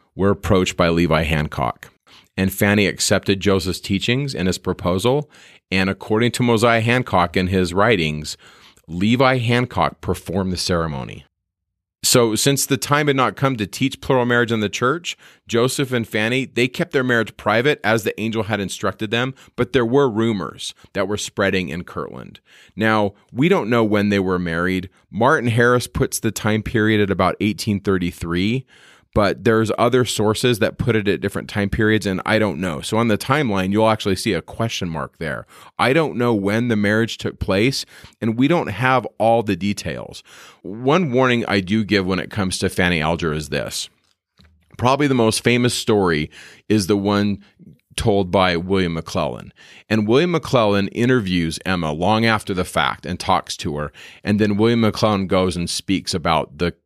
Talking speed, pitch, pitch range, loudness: 180 wpm, 105 Hz, 95-120 Hz, -19 LUFS